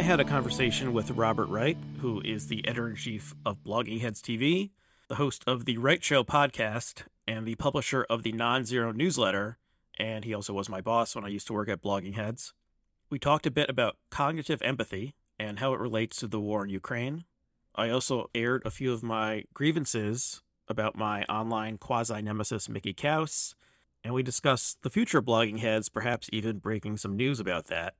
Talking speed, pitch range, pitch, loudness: 190 wpm, 110-130 Hz, 115 Hz, -30 LUFS